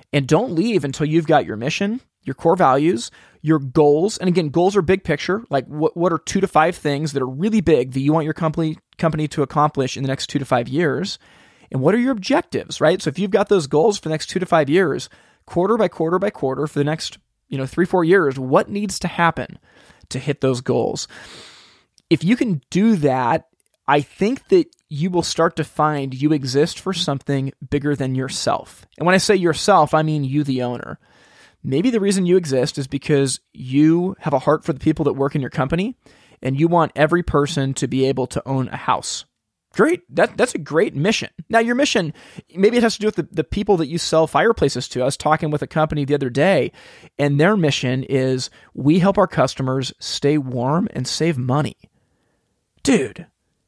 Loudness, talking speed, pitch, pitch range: -19 LUFS, 215 wpm, 155 Hz, 140-180 Hz